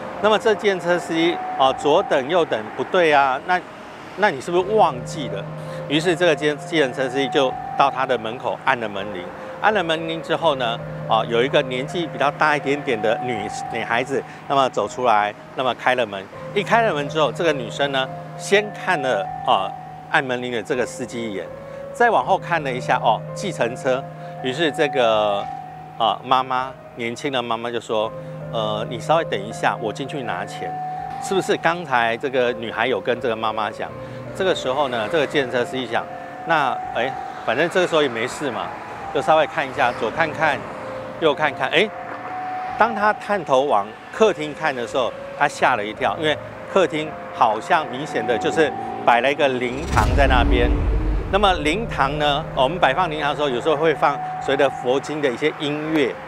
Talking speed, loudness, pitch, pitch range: 280 characters per minute, -21 LUFS, 155 Hz, 130-205 Hz